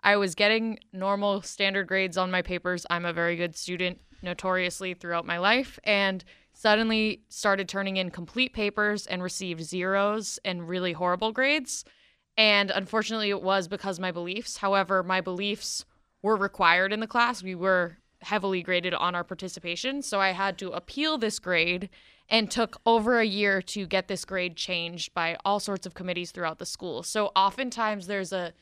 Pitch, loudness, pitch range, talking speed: 195 Hz, -27 LUFS, 180-210 Hz, 175 wpm